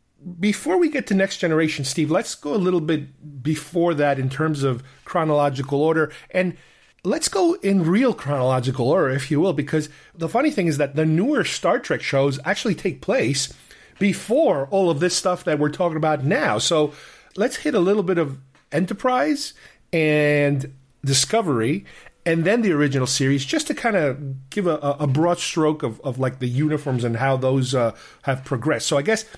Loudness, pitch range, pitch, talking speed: -21 LUFS, 140-185 Hz, 155 Hz, 185 wpm